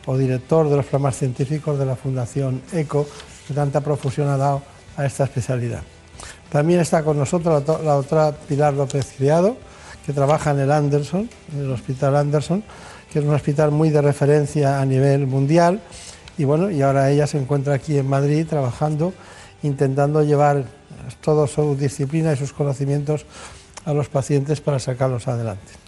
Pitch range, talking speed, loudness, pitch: 135-150 Hz, 165 wpm, -20 LUFS, 145 Hz